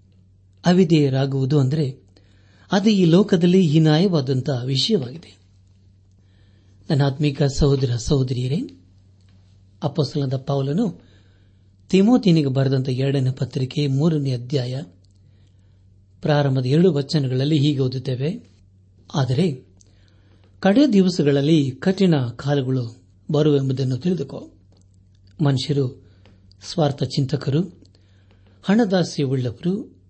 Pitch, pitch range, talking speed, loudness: 135 Hz, 95-150 Hz, 70 wpm, -20 LUFS